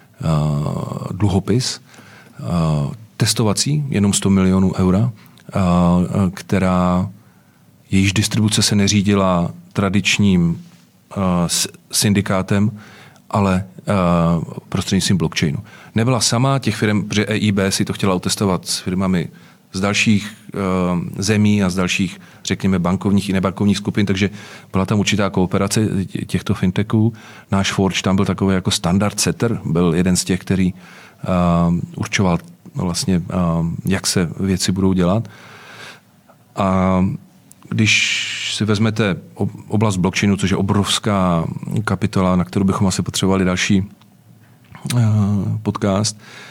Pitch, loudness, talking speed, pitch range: 100 Hz, -18 LUFS, 110 wpm, 95-105 Hz